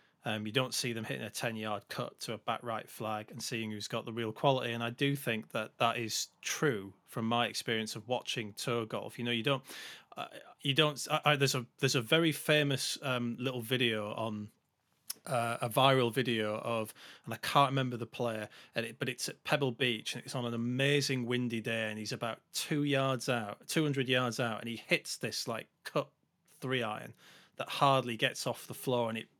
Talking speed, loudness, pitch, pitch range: 215 wpm, -33 LUFS, 120 Hz, 115-135 Hz